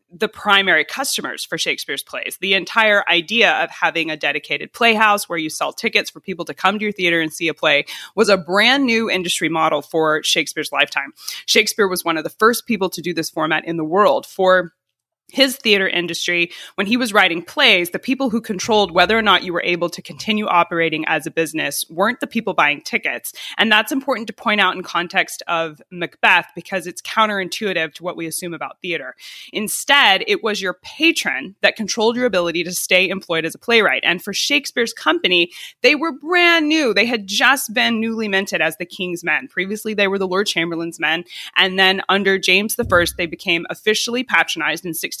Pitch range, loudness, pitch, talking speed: 170-220 Hz, -17 LUFS, 190 Hz, 200 wpm